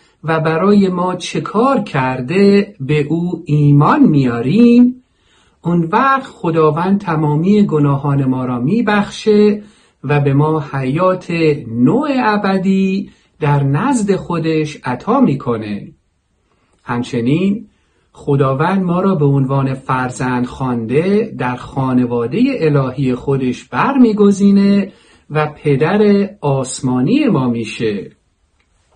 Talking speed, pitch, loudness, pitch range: 95 wpm, 155 Hz, -14 LUFS, 135-200 Hz